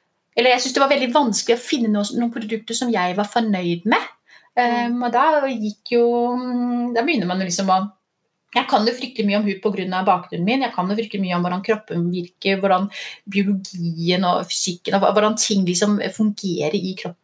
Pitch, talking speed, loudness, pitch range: 210 Hz, 200 wpm, -20 LUFS, 185-240 Hz